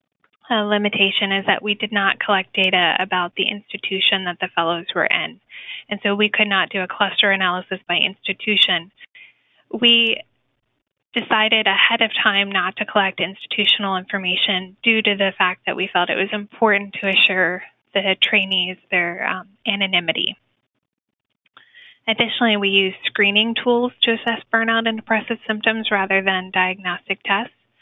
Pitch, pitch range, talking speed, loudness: 200 Hz, 185-220 Hz, 150 wpm, -18 LUFS